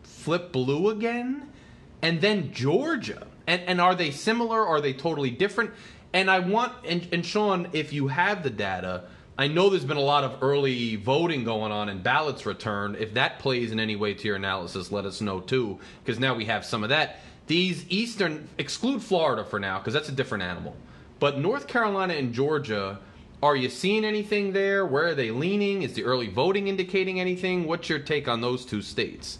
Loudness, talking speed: -26 LUFS, 200 wpm